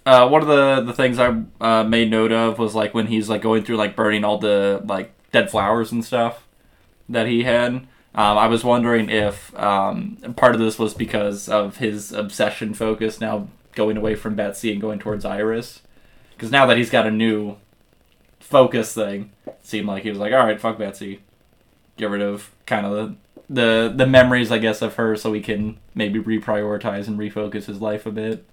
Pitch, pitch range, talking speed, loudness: 110 Hz, 105-115 Hz, 205 wpm, -19 LUFS